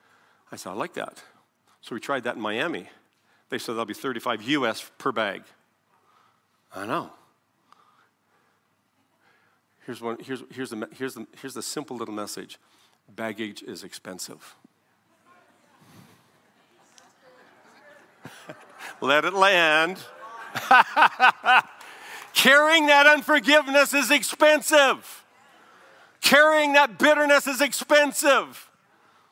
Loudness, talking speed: -20 LUFS, 90 wpm